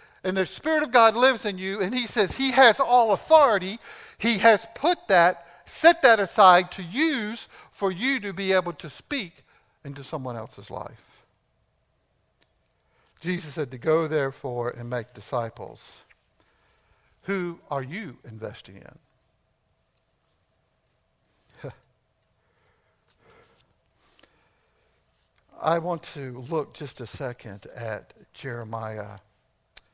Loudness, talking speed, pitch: -23 LUFS, 115 wpm, 165 Hz